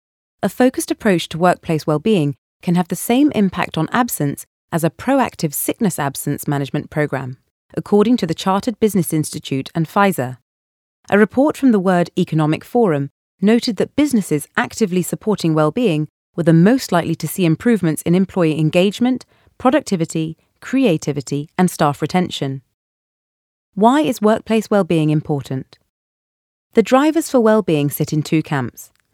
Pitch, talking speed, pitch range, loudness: 170 Hz, 140 wpm, 150-220 Hz, -17 LUFS